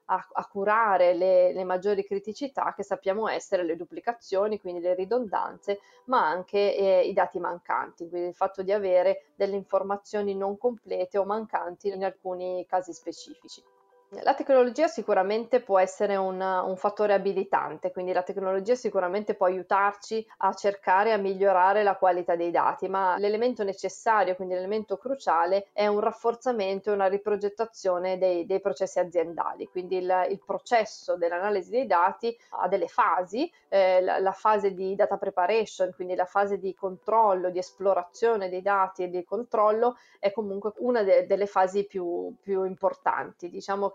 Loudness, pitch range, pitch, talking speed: -27 LUFS, 185-210 Hz, 195 Hz, 155 wpm